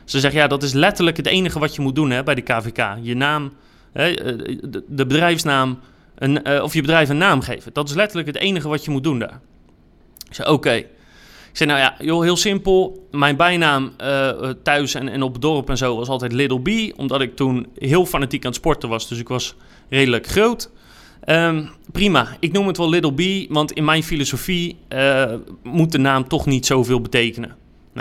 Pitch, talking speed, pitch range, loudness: 140 Hz, 210 wpm, 130-165 Hz, -18 LUFS